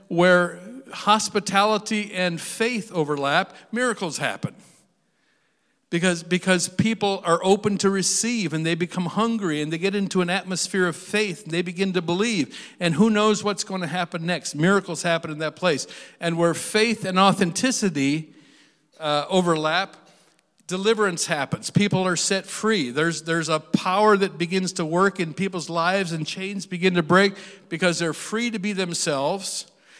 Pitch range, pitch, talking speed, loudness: 170-200 Hz, 185 Hz, 160 wpm, -23 LUFS